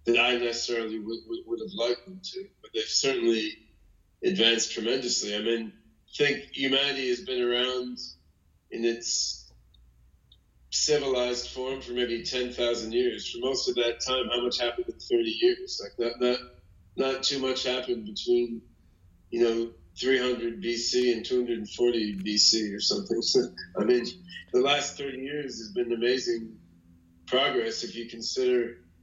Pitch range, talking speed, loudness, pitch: 110-130 Hz, 150 wpm, -27 LUFS, 120 Hz